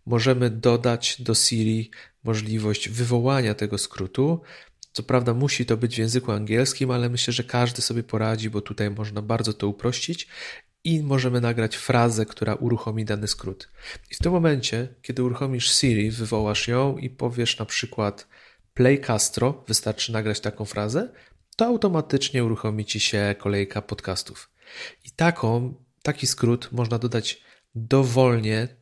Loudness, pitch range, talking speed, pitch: -24 LUFS, 110-130 Hz, 145 wpm, 120 Hz